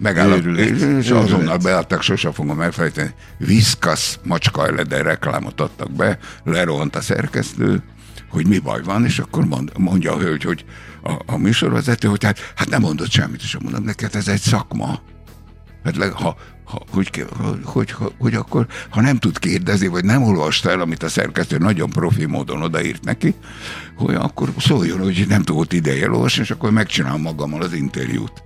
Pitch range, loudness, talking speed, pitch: 85-110 Hz, -18 LUFS, 170 wpm, 100 Hz